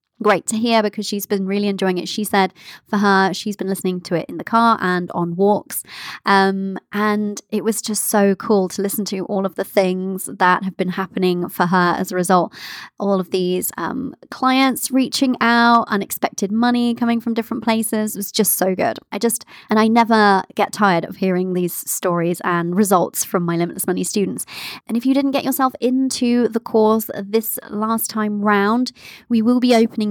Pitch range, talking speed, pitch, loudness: 190-230 Hz, 200 wpm, 210 Hz, -18 LUFS